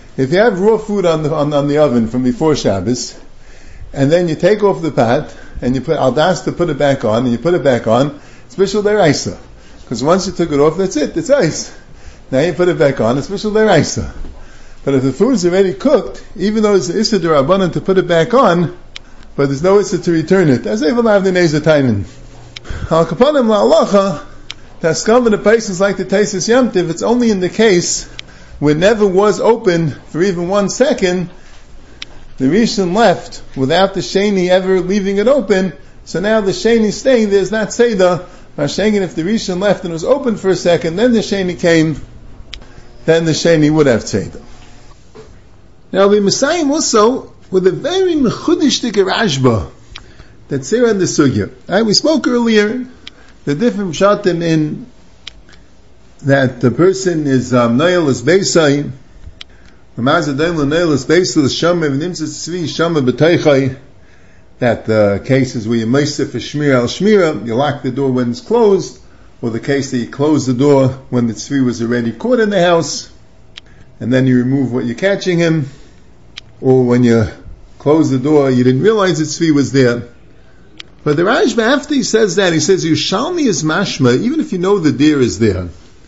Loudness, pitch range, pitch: -13 LUFS, 130-195 Hz, 160 Hz